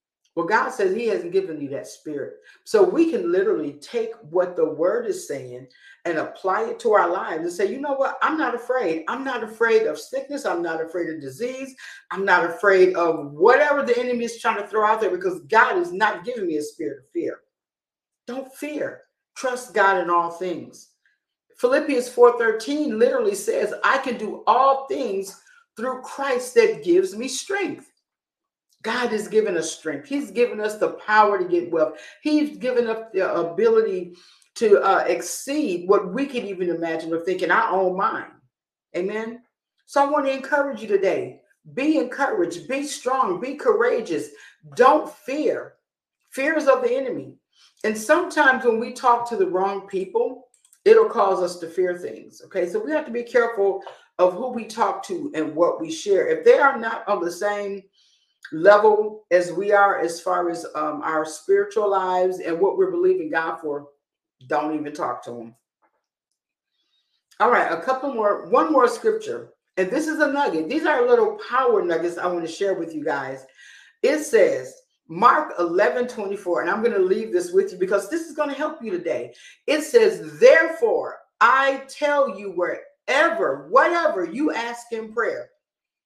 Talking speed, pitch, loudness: 180 wpm, 245 Hz, -21 LUFS